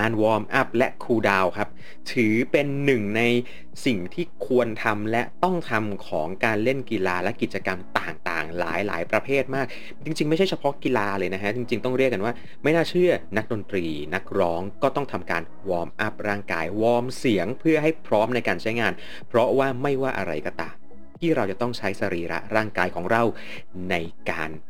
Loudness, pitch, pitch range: -24 LUFS, 110 Hz, 90-130 Hz